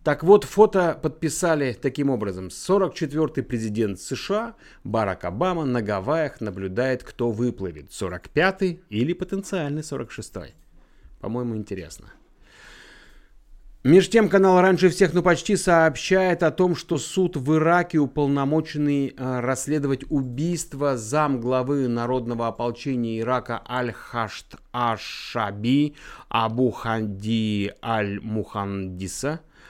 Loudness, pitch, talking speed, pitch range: -23 LUFS, 135 Hz, 100 wpm, 115-165 Hz